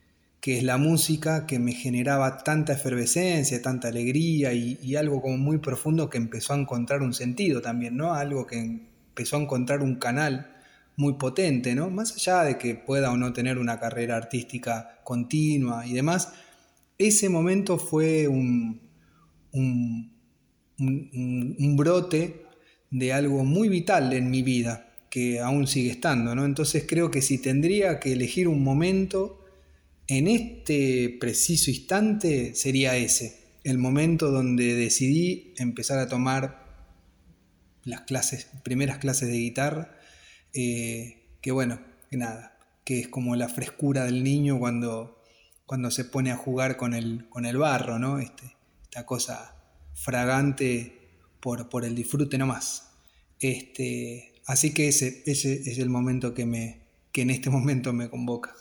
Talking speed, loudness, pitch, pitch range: 150 wpm, -26 LUFS, 130 Hz, 120-140 Hz